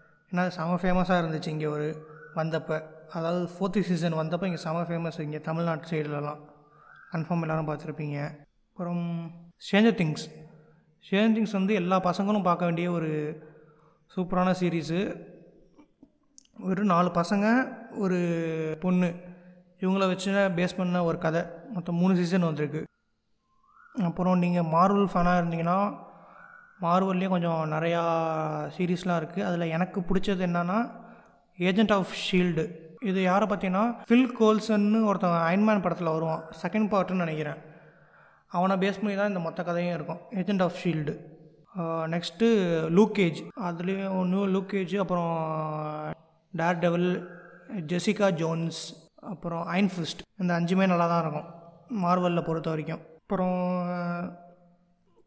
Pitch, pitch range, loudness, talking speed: 175 Hz, 165-190 Hz, -27 LUFS, 120 wpm